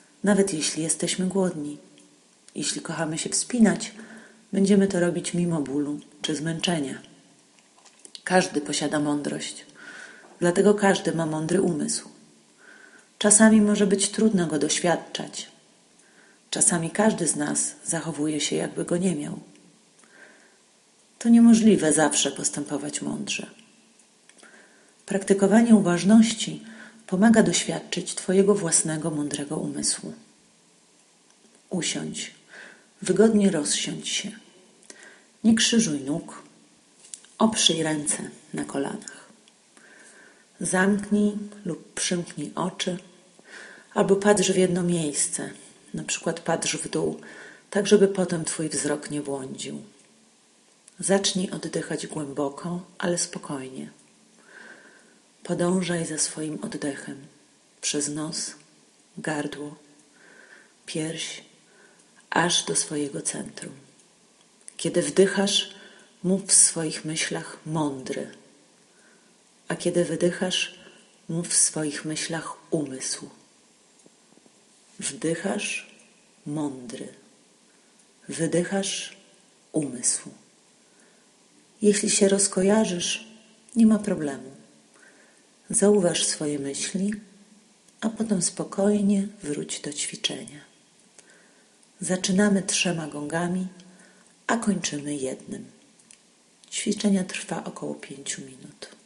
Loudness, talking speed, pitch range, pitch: -24 LUFS, 90 wpm, 155-205 Hz, 180 Hz